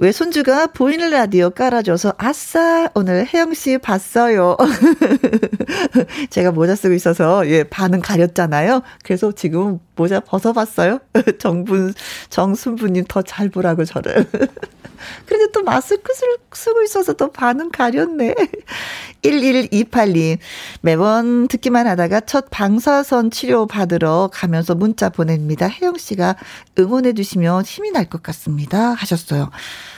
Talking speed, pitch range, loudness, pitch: 265 characters per minute, 180-265 Hz, -16 LUFS, 215 Hz